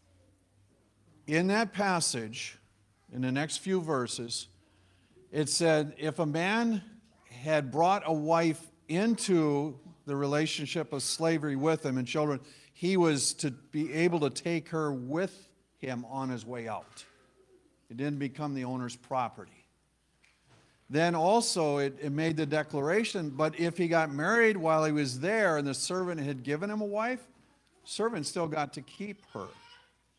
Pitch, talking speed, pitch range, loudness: 155 Hz, 155 wpm, 135-175 Hz, -30 LUFS